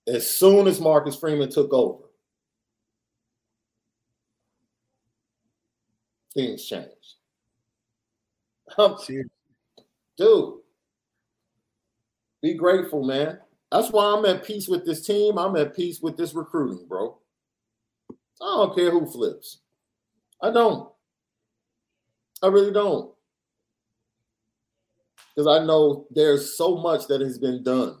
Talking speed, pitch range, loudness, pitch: 105 wpm, 115-190 Hz, -22 LUFS, 140 Hz